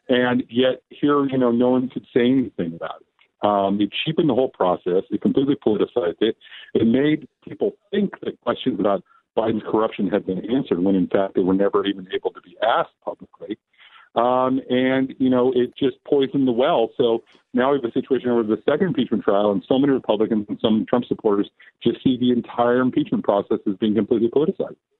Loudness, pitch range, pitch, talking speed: -21 LUFS, 105-135 Hz, 125 Hz, 200 wpm